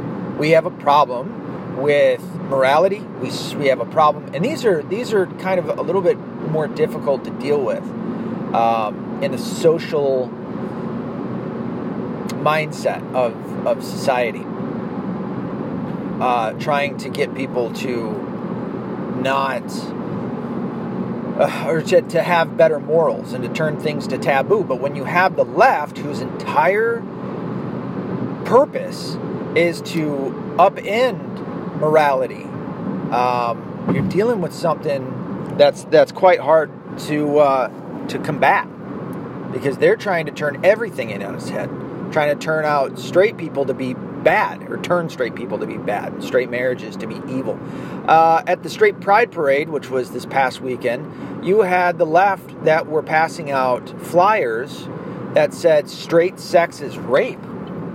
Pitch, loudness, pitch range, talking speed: 165 Hz, -19 LUFS, 145-190 Hz, 140 wpm